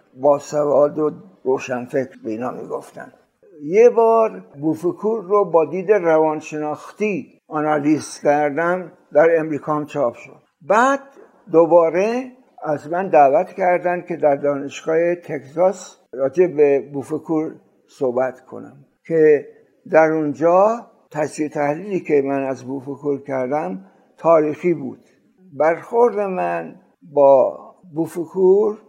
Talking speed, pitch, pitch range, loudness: 105 wpm, 160 Hz, 145-190 Hz, -19 LUFS